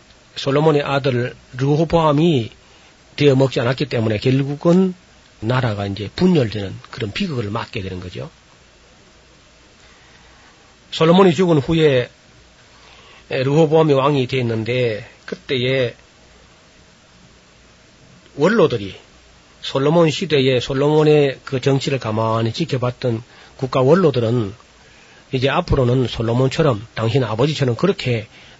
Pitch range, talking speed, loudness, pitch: 115-150 Hz, 250 characters per minute, -18 LUFS, 130 Hz